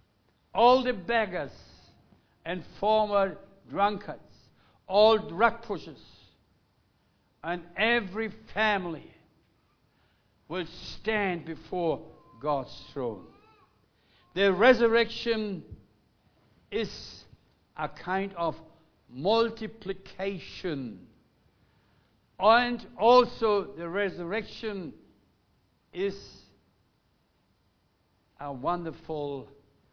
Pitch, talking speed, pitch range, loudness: 190 Hz, 60 wpm, 150-215 Hz, -28 LUFS